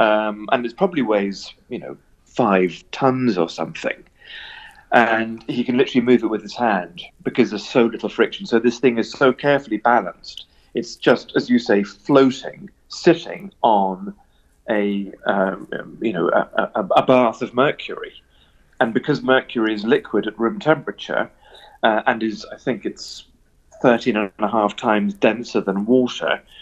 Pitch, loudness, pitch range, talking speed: 115 Hz, -19 LUFS, 100-130 Hz, 160 wpm